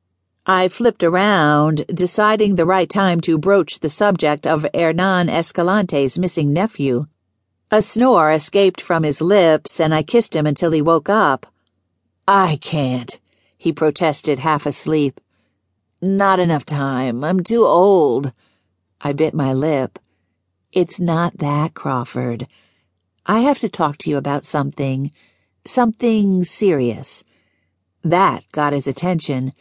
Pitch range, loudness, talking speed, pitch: 135-185 Hz, -17 LUFS, 130 wpm, 155 Hz